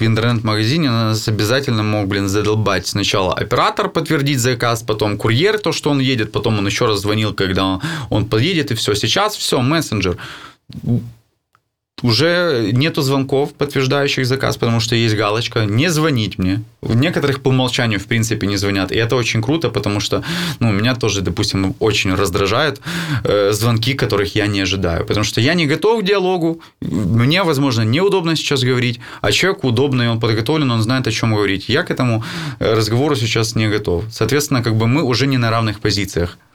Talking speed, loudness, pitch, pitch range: 170 wpm, -16 LUFS, 115 Hz, 105-140 Hz